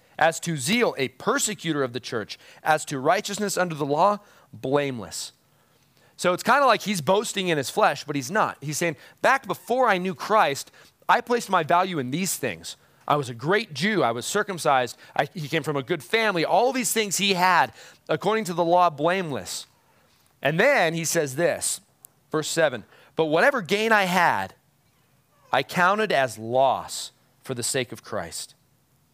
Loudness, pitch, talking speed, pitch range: -23 LUFS, 165 Hz, 180 wpm, 140-200 Hz